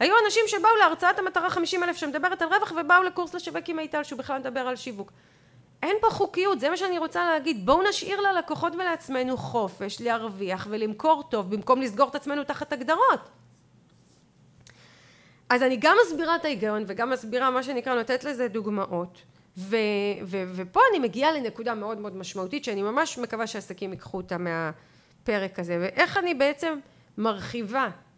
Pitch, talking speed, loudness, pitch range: 260 Hz, 160 wpm, -26 LUFS, 215-335 Hz